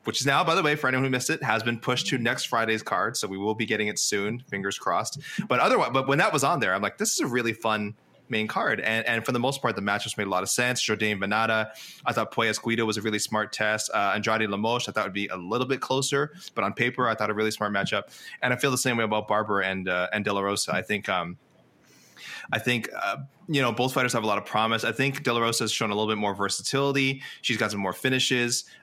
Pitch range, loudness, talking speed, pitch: 105-130 Hz, -26 LUFS, 280 wpm, 115 Hz